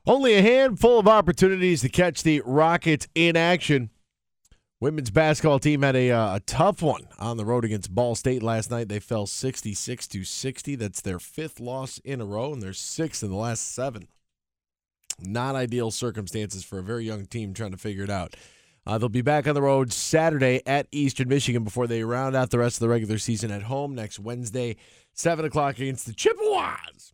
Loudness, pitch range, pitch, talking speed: -24 LUFS, 110-150 Hz, 125 Hz, 200 wpm